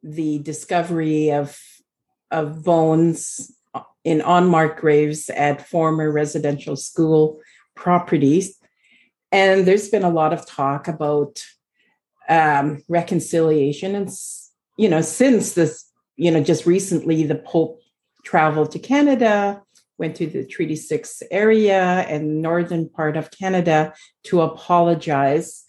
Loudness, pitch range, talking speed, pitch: -19 LUFS, 155-175 Hz, 115 wpm, 160 Hz